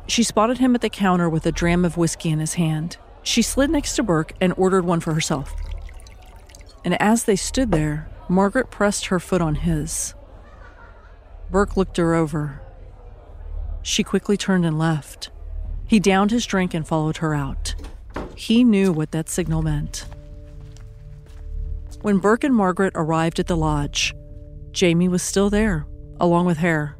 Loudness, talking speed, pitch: -21 LUFS, 160 wpm, 165 Hz